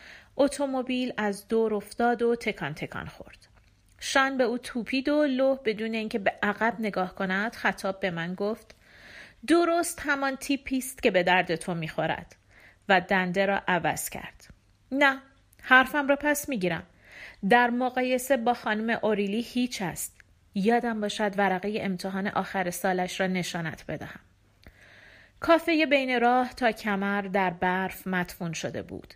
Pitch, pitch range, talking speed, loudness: 215 Hz, 185-255 Hz, 140 wpm, -27 LUFS